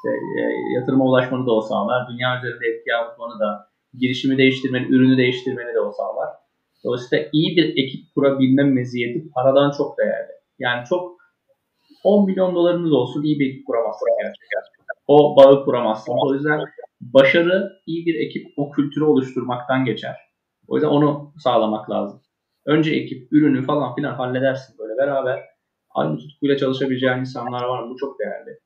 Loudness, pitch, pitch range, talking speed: -19 LUFS, 135 Hz, 125-150 Hz, 155 wpm